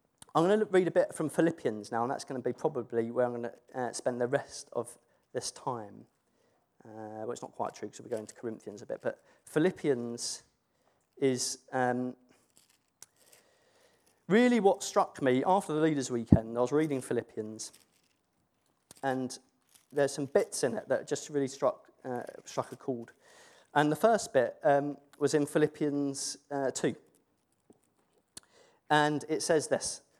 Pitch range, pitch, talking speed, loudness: 125-165 Hz, 140 Hz, 165 wpm, -31 LUFS